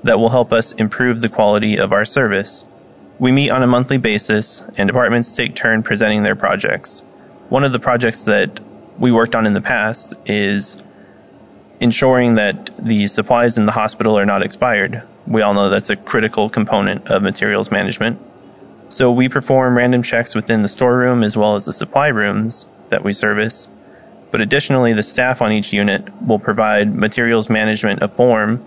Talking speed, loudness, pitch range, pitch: 180 wpm, -15 LUFS, 105-125 Hz, 110 Hz